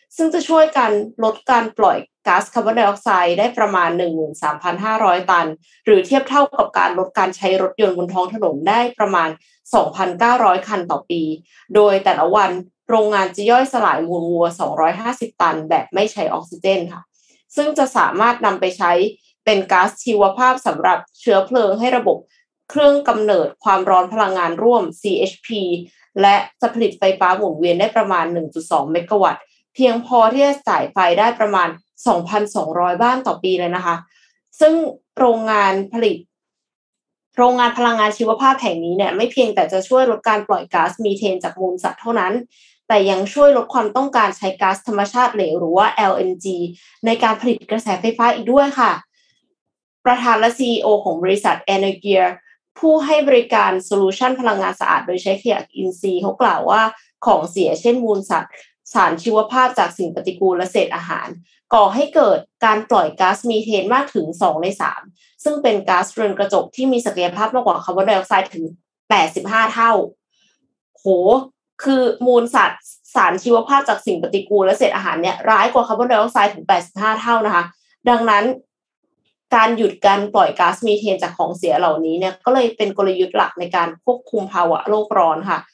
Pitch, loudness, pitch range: 210 Hz, -16 LUFS, 185-240 Hz